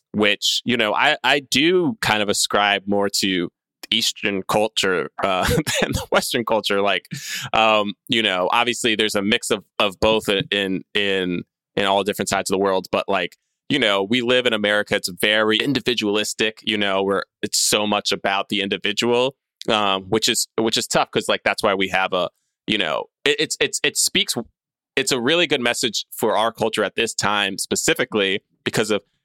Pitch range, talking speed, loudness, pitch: 100-115 Hz, 190 wpm, -20 LUFS, 105 Hz